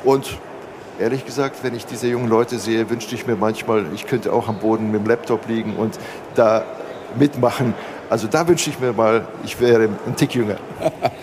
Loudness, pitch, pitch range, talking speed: -20 LUFS, 115 Hz, 110-125 Hz, 190 wpm